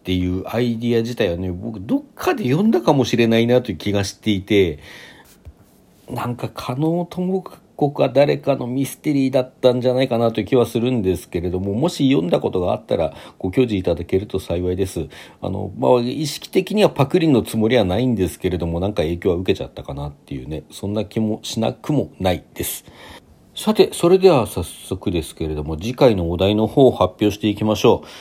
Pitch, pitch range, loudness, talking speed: 115 Hz, 95-135 Hz, -19 LUFS, 415 characters per minute